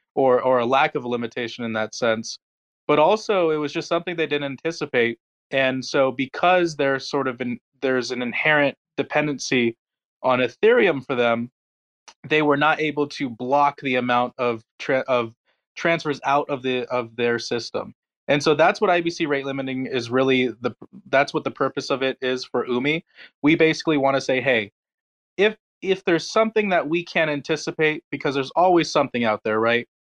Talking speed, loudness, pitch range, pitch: 185 wpm, -22 LUFS, 125-155 Hz, 135 Hz